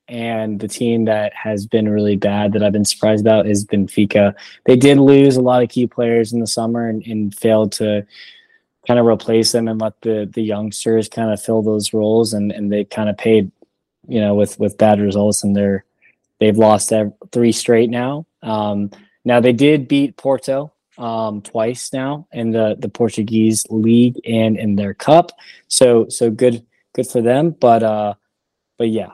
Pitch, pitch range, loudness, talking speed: 110 Hz, 105-120 Hz, -16 LUFS, 190 wpm